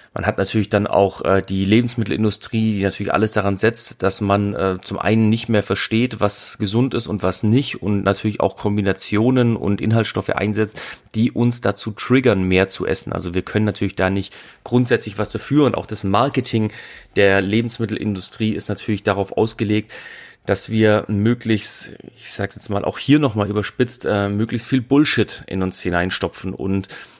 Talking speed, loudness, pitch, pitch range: 175 wpm, -19 LUFS, 105 Hz, 100-115 Hz